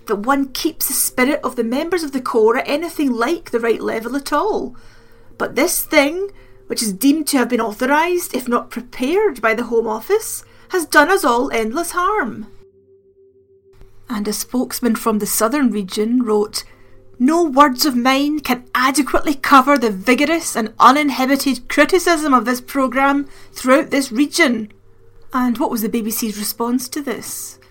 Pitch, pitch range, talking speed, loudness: 265 Hz, 230-305 Hz, 165 wpm, -17 LUFS